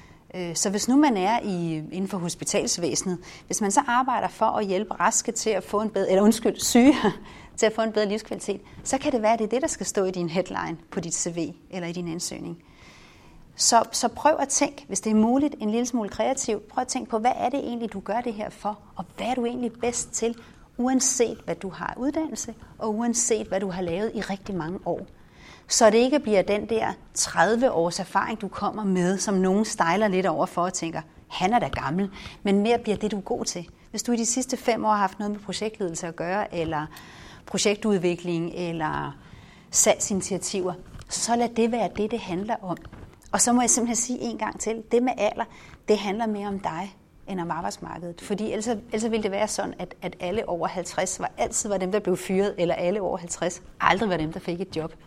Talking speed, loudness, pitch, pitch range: 225 wpm, -25 LUFS, 205 Hz, 180-230 Hz